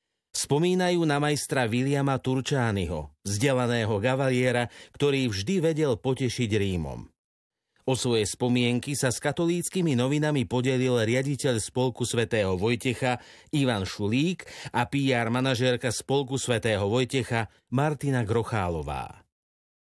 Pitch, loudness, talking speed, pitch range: 125 Hz, -26 LUFS, 105 wpm, 115-140 Hz